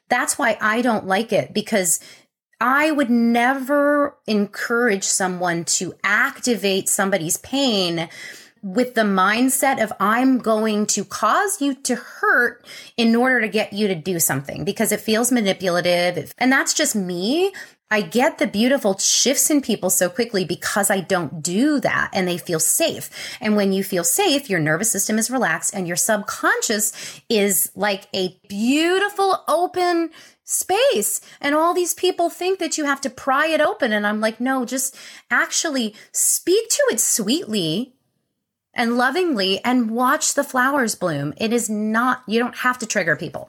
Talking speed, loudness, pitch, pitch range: 165 wpm, -19 LUFS, 230 Hz, 200-275 Hz